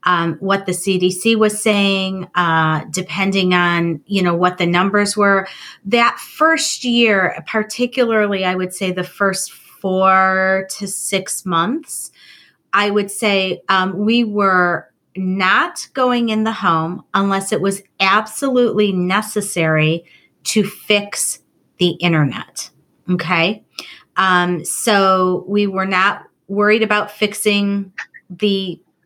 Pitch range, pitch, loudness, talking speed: 180-210 Hz, 195 Hz, -16 LUFS, 120 wpm